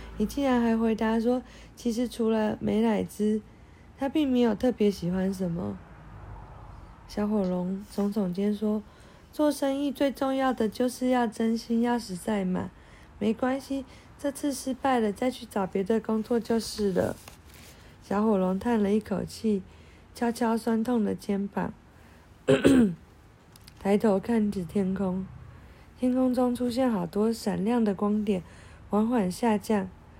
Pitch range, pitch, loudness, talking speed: 195-240 Hz, 215 Hz, -28 LUFS, 205 characters per minute